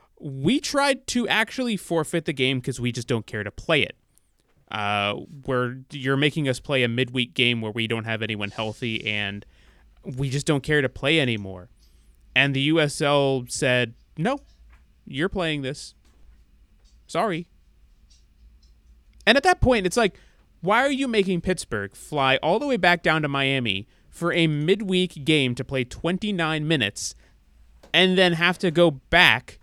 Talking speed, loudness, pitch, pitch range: 160 wpm, -23 LUFS, 130 Hz, 100-165 Hz